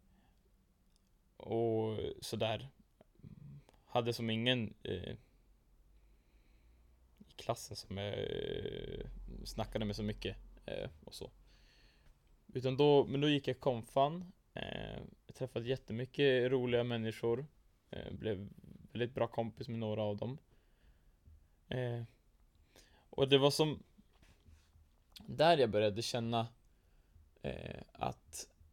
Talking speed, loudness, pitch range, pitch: 105 wpm, -37 LUFS, 85-125 Hz, 110 Hz